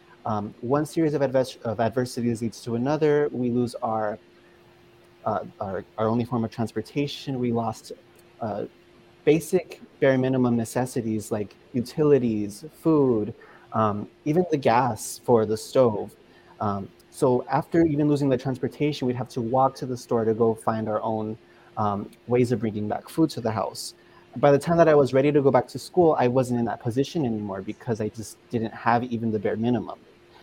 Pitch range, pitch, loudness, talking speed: 110-140 Hz, 120 Hz, -25 LUFS, 180 wpm